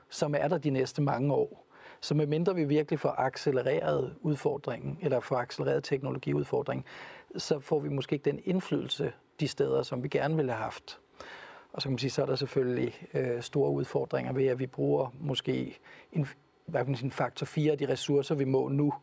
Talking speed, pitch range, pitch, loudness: 185 wpm, 135-155 Hz, 145 Hz, -31 LUFS